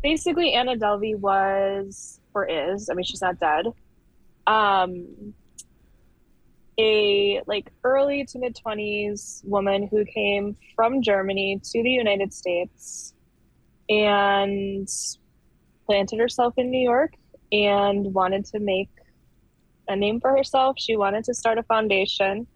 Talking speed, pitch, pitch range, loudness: 125 wpm, 210 Hz, 195-245 Hz, -23 LUFS